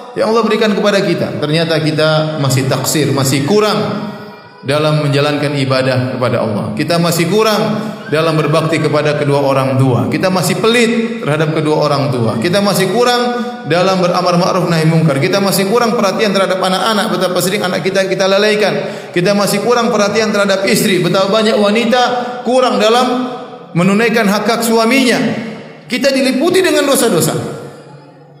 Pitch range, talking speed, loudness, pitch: 155-220 Hz, 145 wpm, -12 LUFS, 195 Hz